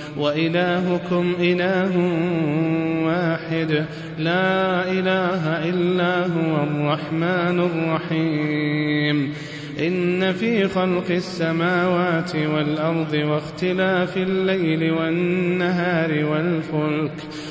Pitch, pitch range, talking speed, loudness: 165 Hz, 155-180 Hz, 60 wpm, -21 LUFS